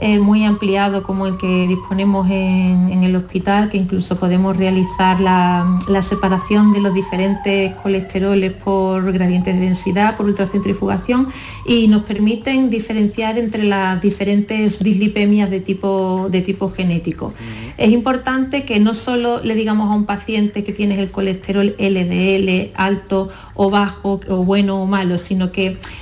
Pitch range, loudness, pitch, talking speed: 190-210 Hz, -16 LUFS, 195 Hz, 150 wpm